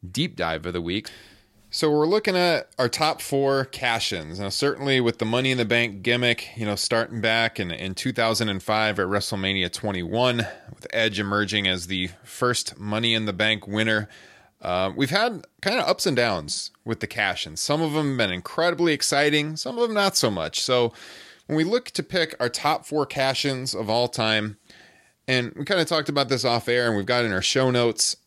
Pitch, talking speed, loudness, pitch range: 115 Hz, 210 wpm, -23 LUFS, 105-140 Hz